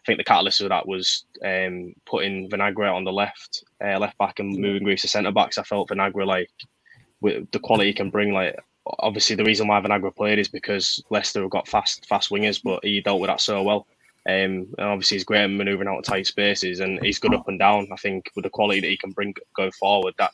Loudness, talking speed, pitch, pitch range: -22 LUFS, 245 wpm, 100 Hz, 95-105 Hz